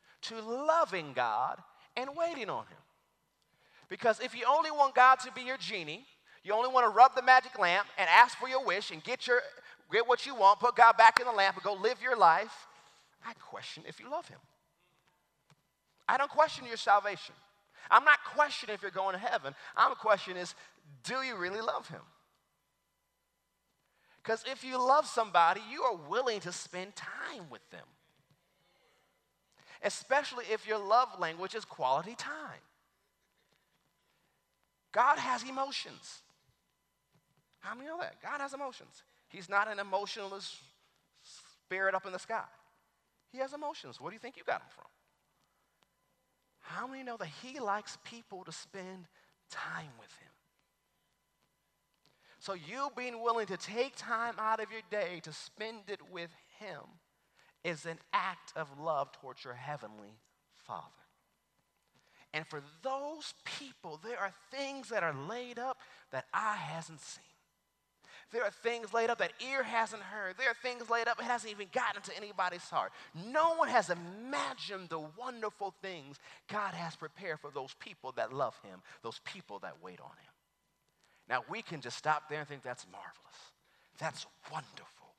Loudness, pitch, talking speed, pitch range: -32 LUFS, 220 Hz, 165 wpm, 185-255 Hz